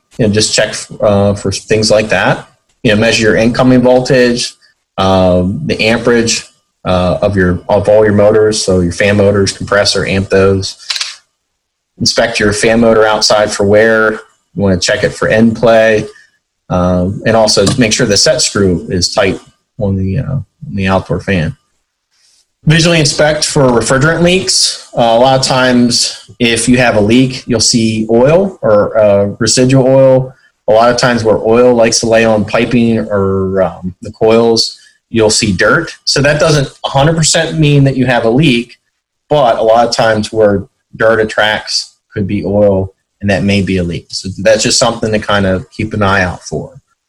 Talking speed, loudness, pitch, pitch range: 185 wpm, -10 LUFS, 110 Hz, 100-125 Hz